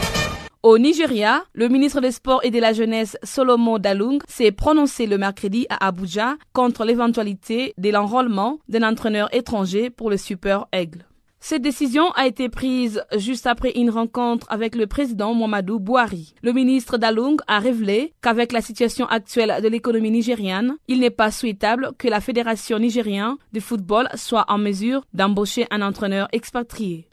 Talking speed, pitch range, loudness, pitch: 160 wpm, 210-250 Hz, -20 LUFS, 230 Hz